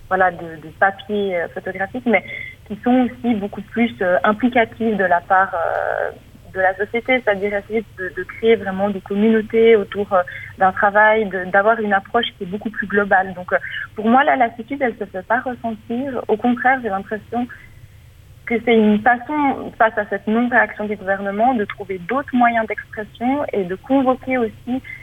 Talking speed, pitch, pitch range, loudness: 185 wpm, 210 Hz, 195-235 Hz, -18 LUFS